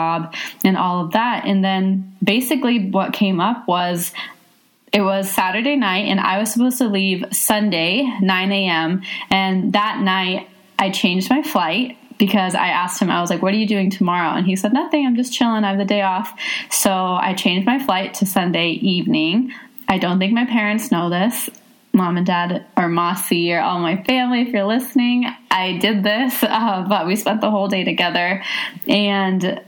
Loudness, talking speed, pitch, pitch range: -18 LUFS, 190 wpm, 200 Hz, 185-235 Hz